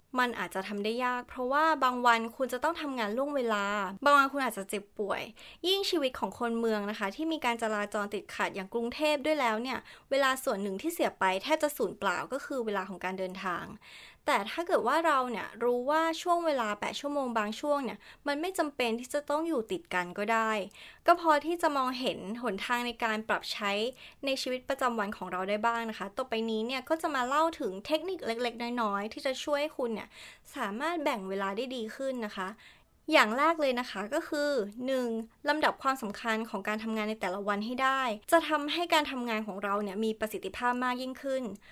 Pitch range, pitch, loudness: 210-290 Hz, 245 Hz, -31 LUFS